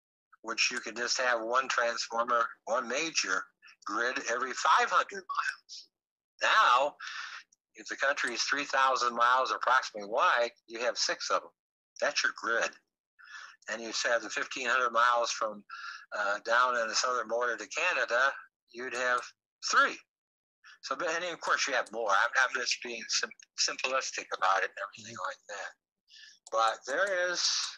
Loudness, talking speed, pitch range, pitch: -30 LUFS, 150 wpm, 115-135 Hz, 120 Hz